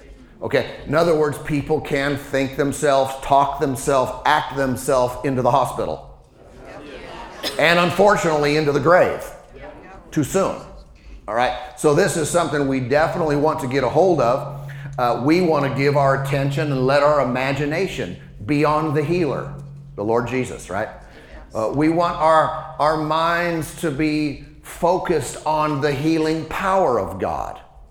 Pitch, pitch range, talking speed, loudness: 145 Hz, 135-155 Hz, 150 wpm, -19 LUFS